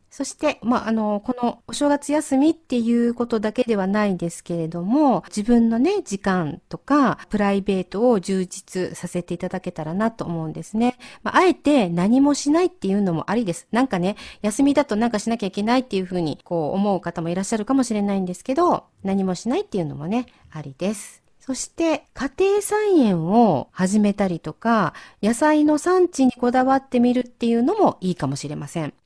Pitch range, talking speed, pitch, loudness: 185-265 Hz, 395 characters per minute, 220 Hz, -21 LUFS